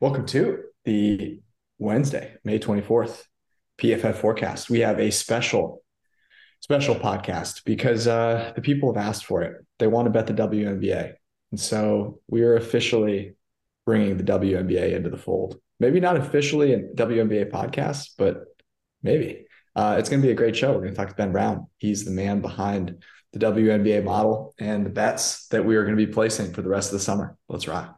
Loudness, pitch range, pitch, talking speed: -23 LUFS, 100-115 Hz, 110 Hz, 185 wpm